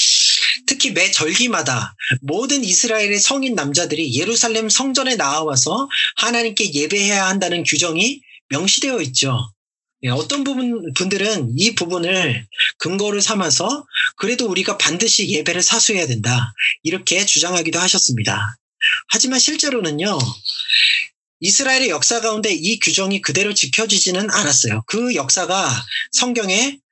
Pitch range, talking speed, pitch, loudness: 160-235 Hz, 310 characters per minute, 195 Hz, -16 LUFS